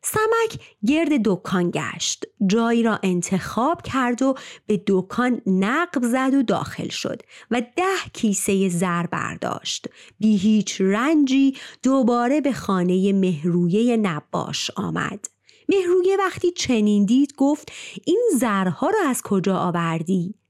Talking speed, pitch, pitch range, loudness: 120 wpm, 230 Hz, 195-275 Hz, -21 LUFS